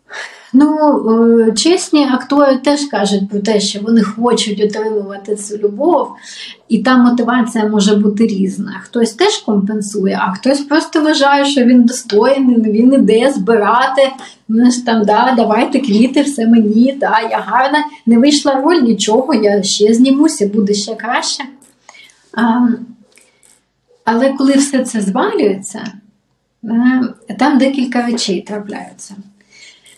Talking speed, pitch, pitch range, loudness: 125 wpm, 230 Hz, 210-270 Hz, -12 LUFS